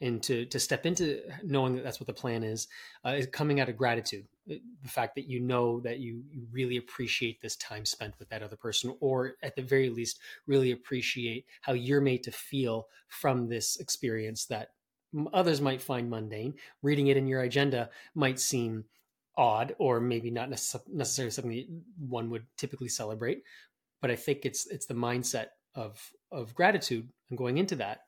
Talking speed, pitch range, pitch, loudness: 185 wpm, 115-135 Hz, 125 Hz, -32 LUFS